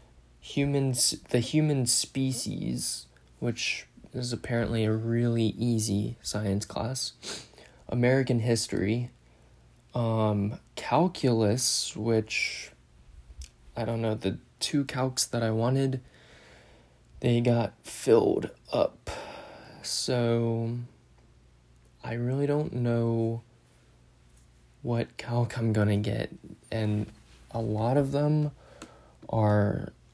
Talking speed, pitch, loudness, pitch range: 90 wpm, 115 Hz, -28 LUFS, 100-120 Hz